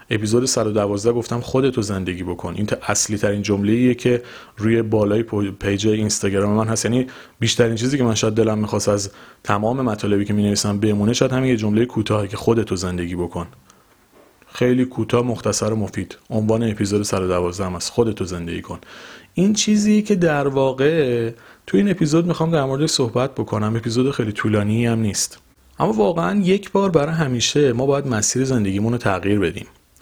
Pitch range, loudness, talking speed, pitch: 105-130 Hz, -19 LUFS, 170 wpm, 110 Hz